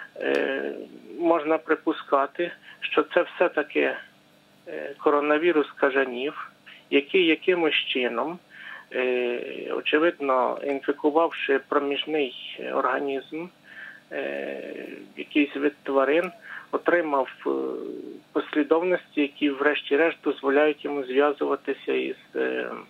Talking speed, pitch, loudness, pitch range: 65 wpm, 145 Hz, -25 LUFS, 135-160 Hz